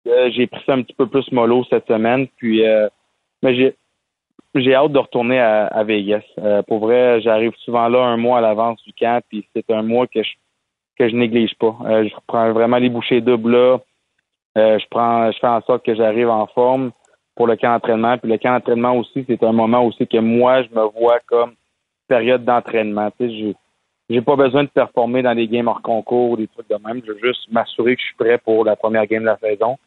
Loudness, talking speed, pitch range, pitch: -17 LUFS, 230 wpm, 110-125 Hz, 115 Hz